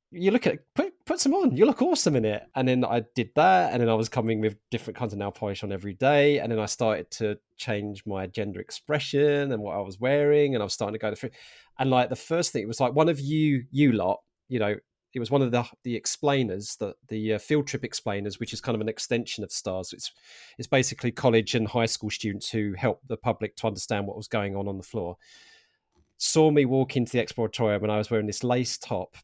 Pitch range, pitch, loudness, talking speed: 105-135 Hz, 115 Hz, -26 LUFS, 250 wpm